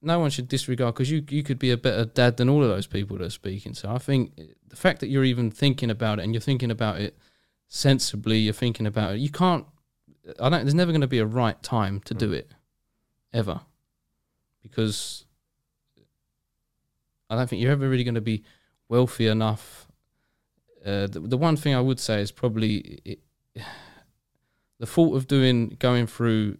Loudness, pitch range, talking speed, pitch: -25 LUFS, 110-135 Hz, 195 wpm, 120 Hz